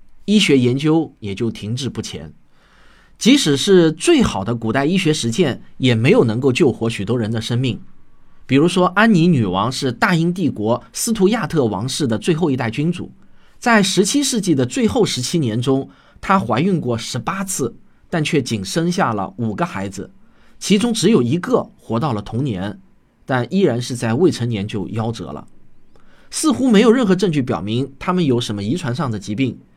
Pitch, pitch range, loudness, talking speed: 135 Hz, 115-180 Hz, -17 LUFS, 270 characters per minute